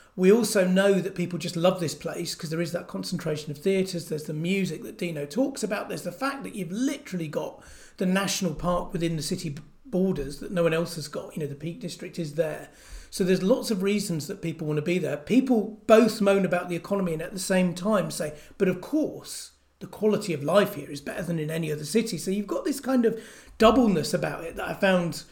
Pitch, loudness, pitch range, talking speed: 180 Hz, -26 LUFS, 165-205 Hz, 235 wpm